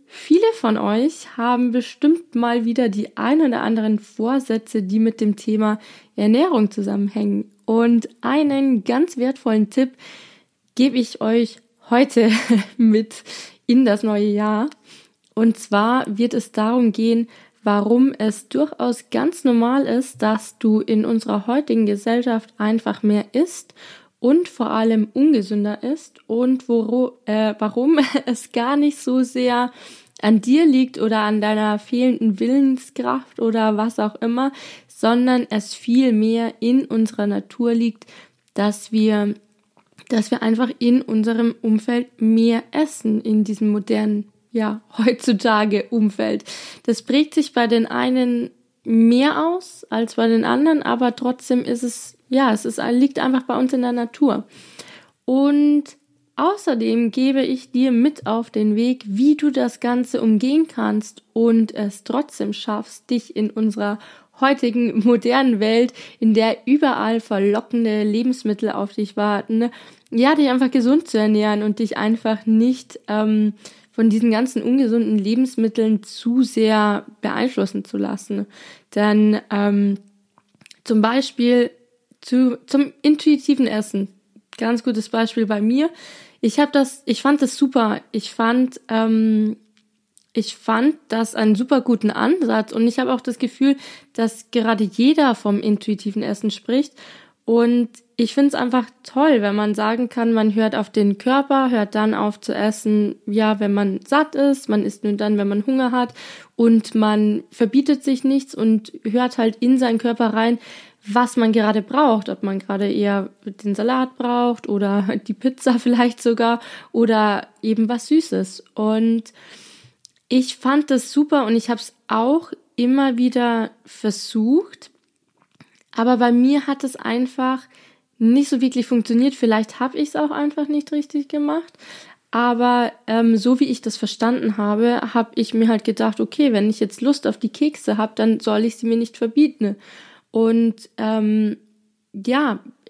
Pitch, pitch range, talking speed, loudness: 230 Hz, 215-260 Hz, 150 wpm, -19 LUFS